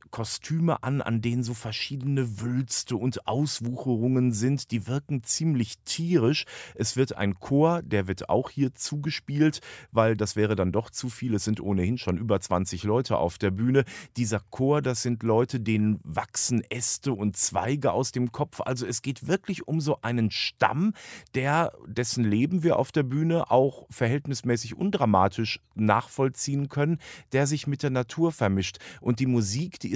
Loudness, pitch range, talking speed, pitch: -26 LUFS, 110-140 Hz, 170 wpm, 125 Hz